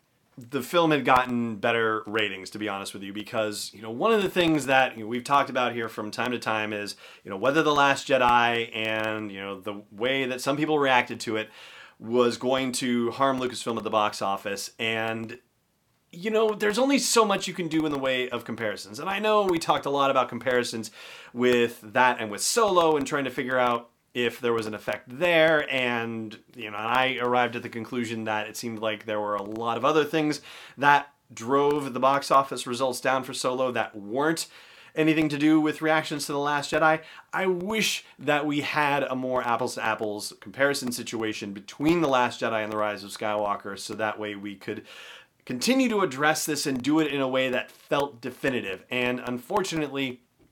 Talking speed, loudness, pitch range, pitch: 210 wpm, -26 LUFS, 110-145 Hz, 125 Hz